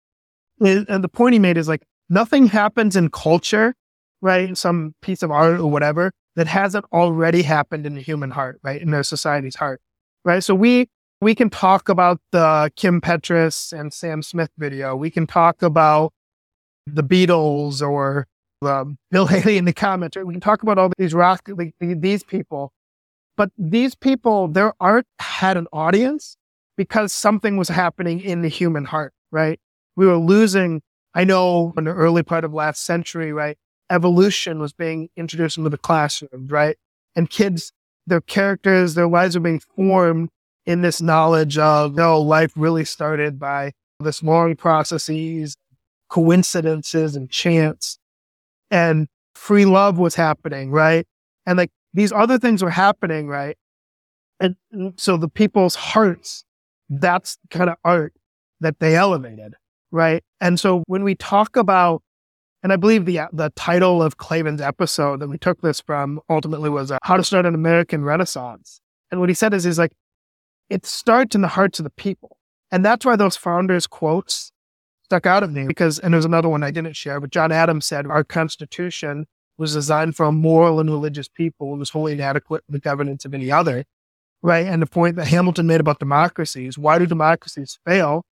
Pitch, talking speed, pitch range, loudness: 165 Hz, 175 wpm, 150-185 Hz, -18 LUFS